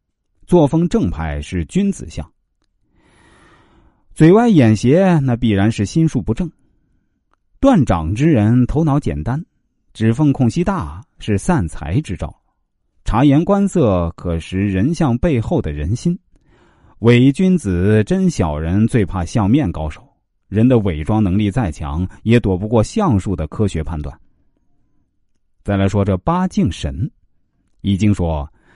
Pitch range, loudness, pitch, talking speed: 95-145 Hz, -16 LUFS, 110 Hz, 190 characters per minute